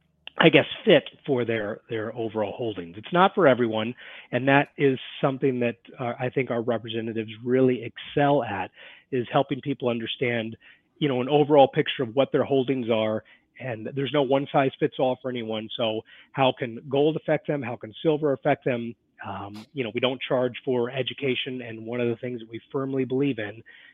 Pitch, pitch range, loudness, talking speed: 125 Hz, 115-140 Hz, -25 LUFS, 195 wpm